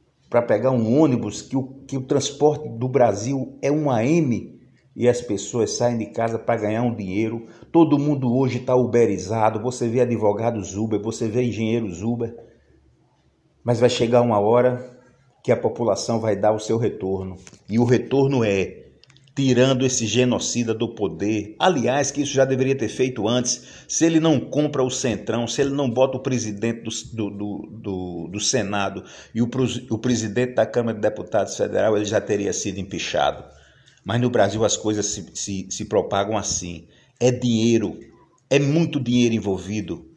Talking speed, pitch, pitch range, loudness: 170 wpm, 120 Hz, 105-130 Hz, -22 LUFS